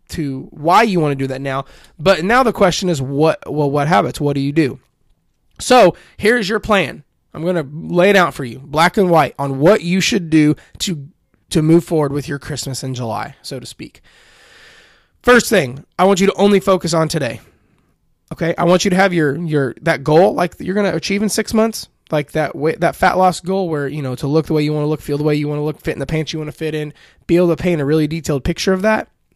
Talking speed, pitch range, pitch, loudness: 255 wpm, 145-185 Hz, 160 Hz, -16 LUFS